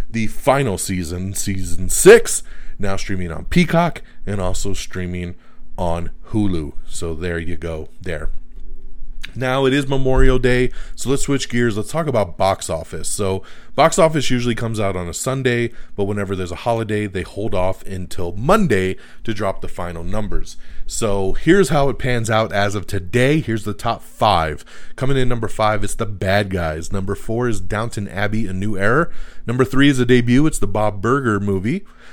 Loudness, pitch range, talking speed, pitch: -19 LUFS, 90-120 Hz, 180 wpm, 105 Hz